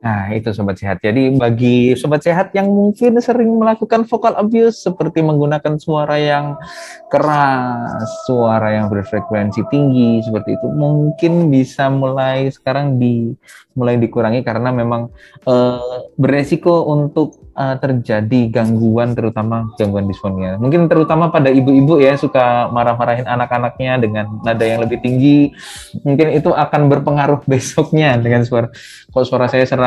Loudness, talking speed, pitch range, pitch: -14 LUFS, 135 wpm, 120-150 Hz, 130 Hz